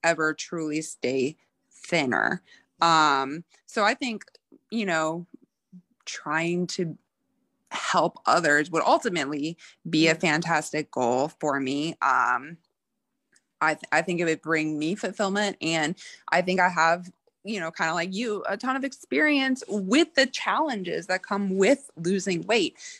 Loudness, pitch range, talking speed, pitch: -25 LUFS, 160-220 Hz, 145 wpm, 175 Hz